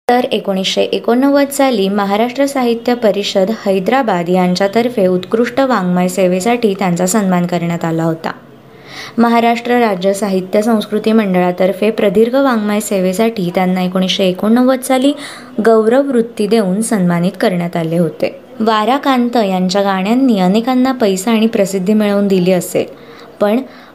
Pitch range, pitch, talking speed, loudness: 185-235 Hz, 210 Hz, 120 wpm, -13 LUFS